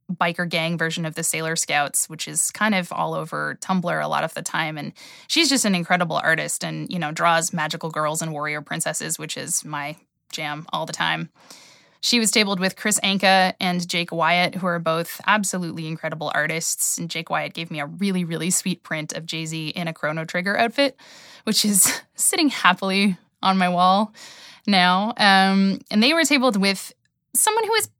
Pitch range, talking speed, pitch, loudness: 160-200 Hz, 195 wpm, 180 Hz, -21 LUFS